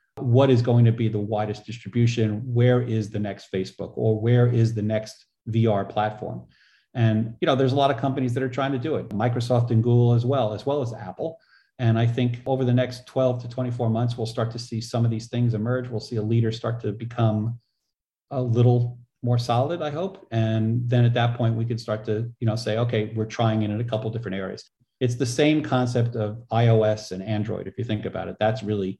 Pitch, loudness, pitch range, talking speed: 115 Hz, -24 LUFS, 110-125 Hz, 230 wpm